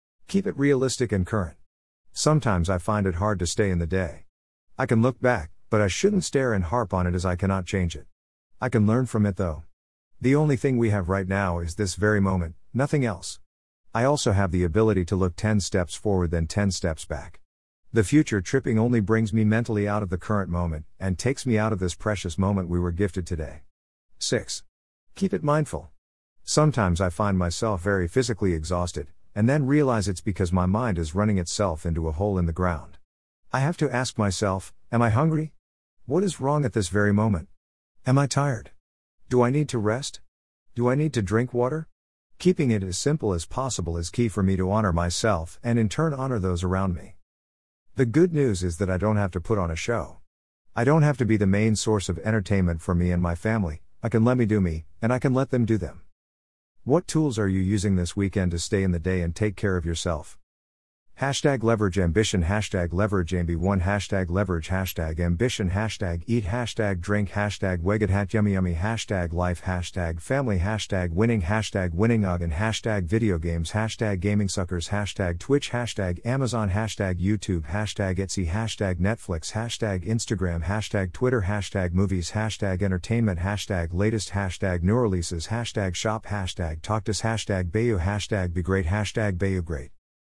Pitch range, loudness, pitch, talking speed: 90-110 Hz, -25 LUFS, 100 Hz, 195 wpm